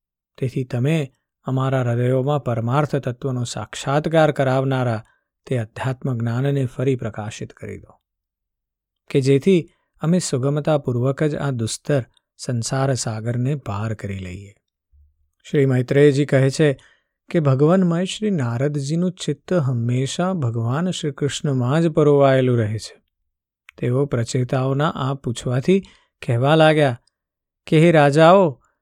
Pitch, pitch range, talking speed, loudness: 135 Hz, 120-150 Hz, 110 wpm, -20 LUFS